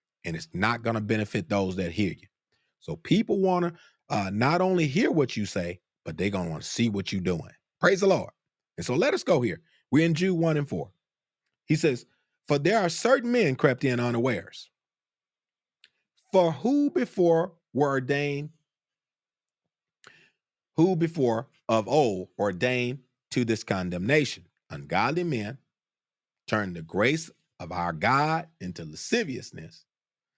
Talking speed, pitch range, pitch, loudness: 155 wpm, 100-165 Hz, 130 Hz, -26 LUFS